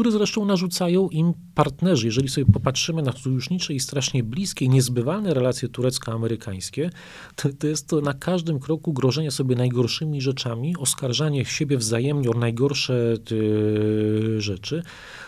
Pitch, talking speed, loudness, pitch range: 135 Hz, 130 wpm, -23 LUFS, 120-160 Hz